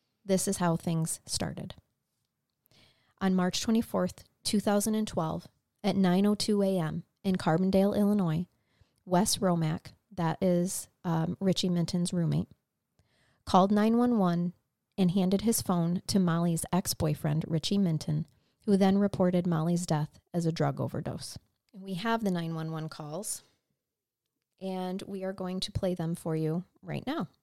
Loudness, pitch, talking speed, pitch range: -30 LUFS, 180 Hz, 130 wpm, 165-195 Hz